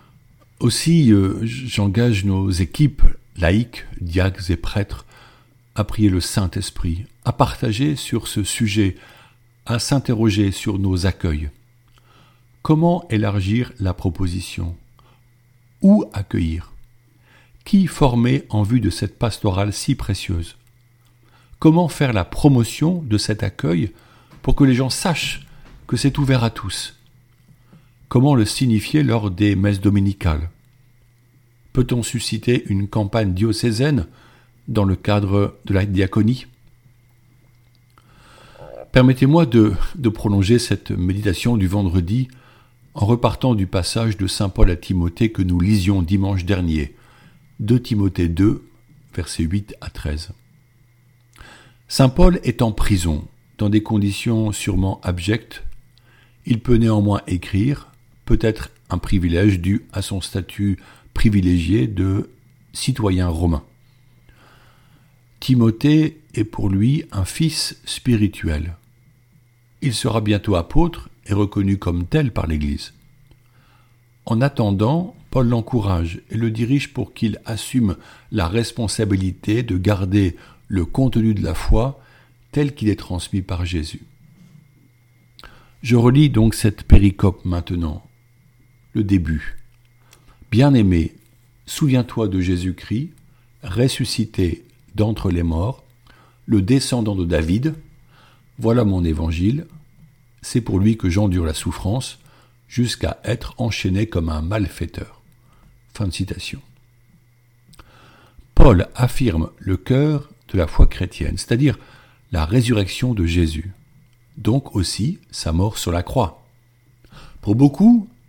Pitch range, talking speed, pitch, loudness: 100-125 Hz, 115 wpm, 115 Hz, -19 LUFS